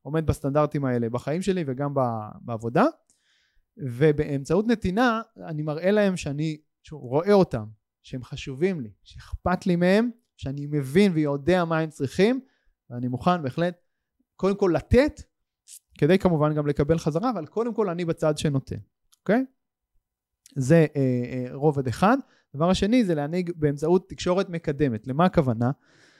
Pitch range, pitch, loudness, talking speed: 140-185 Hz, 160 Hz, -24 LUFS, 135 wpm